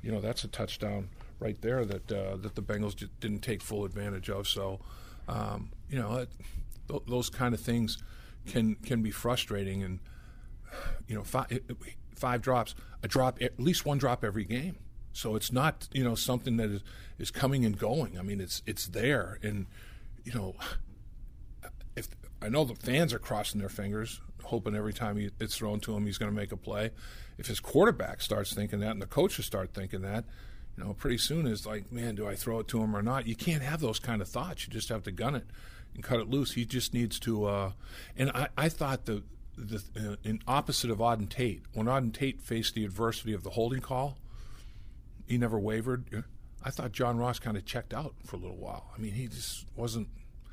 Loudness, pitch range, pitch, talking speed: -33 LUFS, 105-125 Hz, 110 Hz, 210 wpm